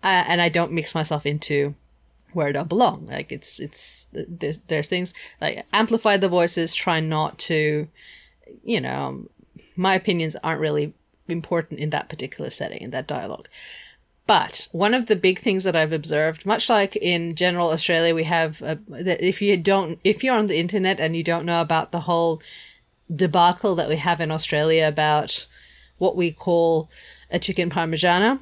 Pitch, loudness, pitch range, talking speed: 170 Hz, -22 LUFS, 160-185 Hz, 175 wpm